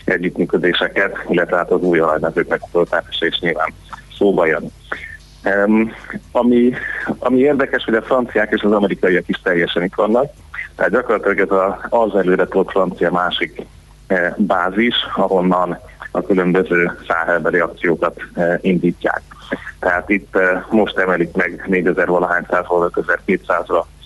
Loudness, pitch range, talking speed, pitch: -17 LUFS, 90-105 Hz, 110 wpm, 95 Hz